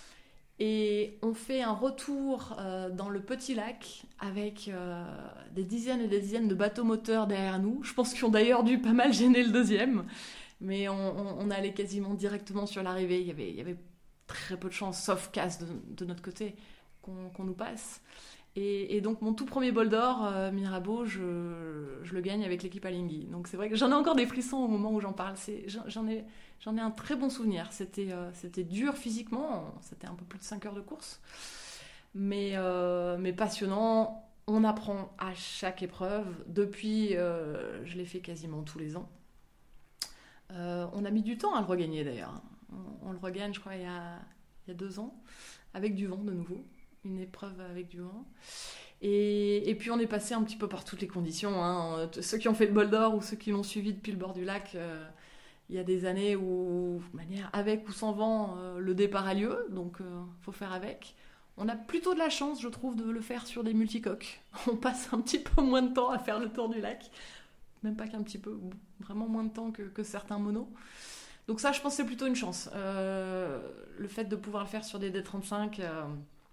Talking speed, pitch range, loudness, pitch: 225 wpm, 185-225 Hz, -33 LUFS, 205 Hz